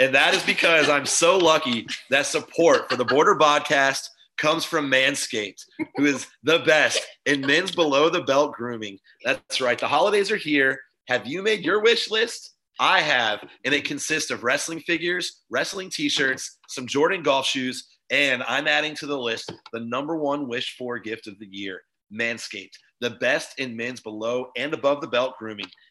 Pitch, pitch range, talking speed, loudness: 140 Hz, 125-165 Hz, 180 wpm, -22 LUFS